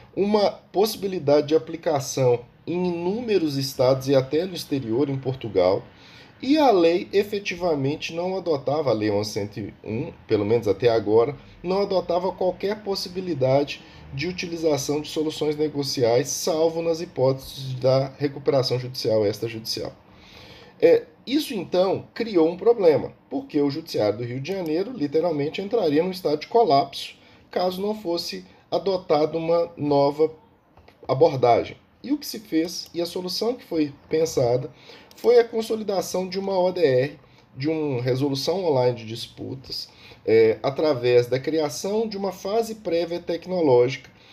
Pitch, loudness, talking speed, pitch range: 160 Hz, -23 LUFS, 135 wpm, 135-190 Hz